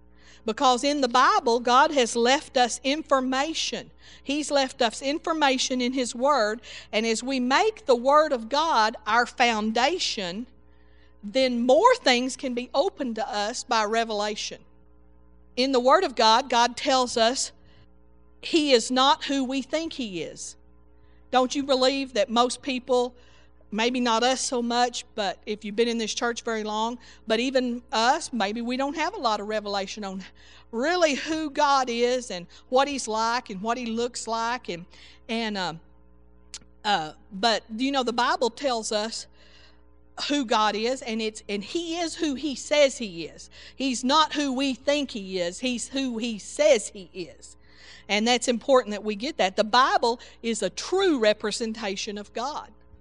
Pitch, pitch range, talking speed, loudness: 240 Hz, 210-270 Hz, 170 wpm, -24 LUFS